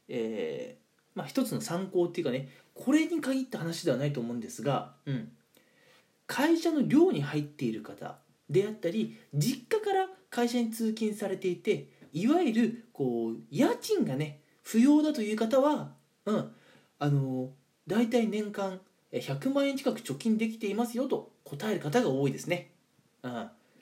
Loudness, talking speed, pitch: -30 LUFS, 290 characters per minute, 215 Hz